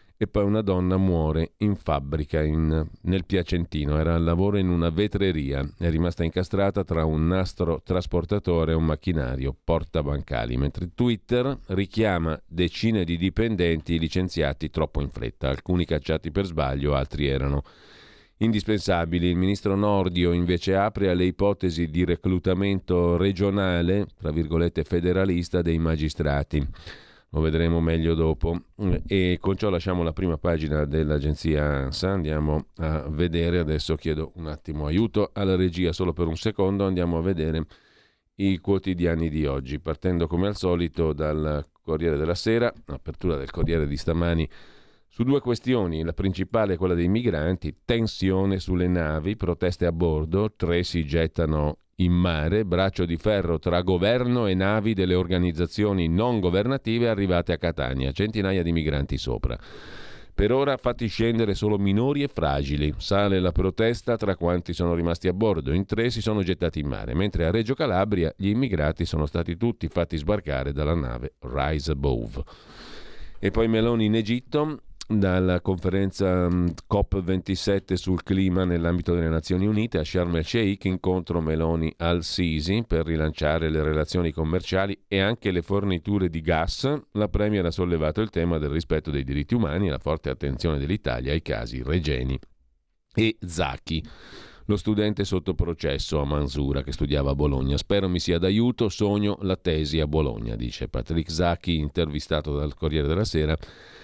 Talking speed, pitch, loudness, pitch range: 150 wpm, 85 Hz, -25 LUFS, 80-100 Hz